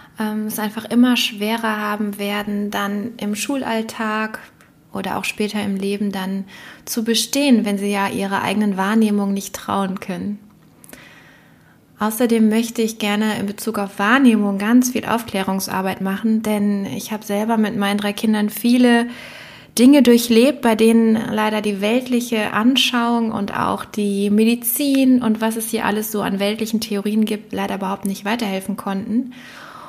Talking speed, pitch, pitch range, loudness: 150 wpm, 215 Hz, 205-230 Hz, -19 LUFS